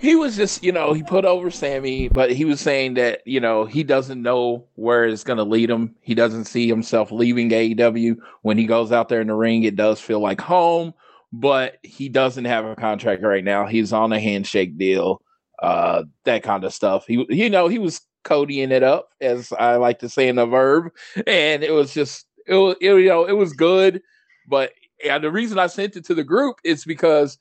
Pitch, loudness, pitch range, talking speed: 130 Hz, -19 LUFS, 115-180 Hz, 225 wpm